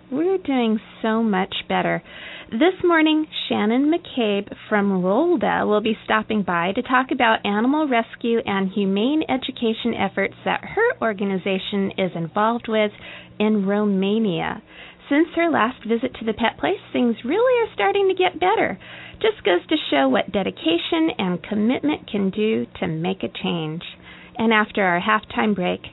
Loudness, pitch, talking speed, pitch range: -21 LUFS, 225 Hz, 155 wpm, 200-300 Hz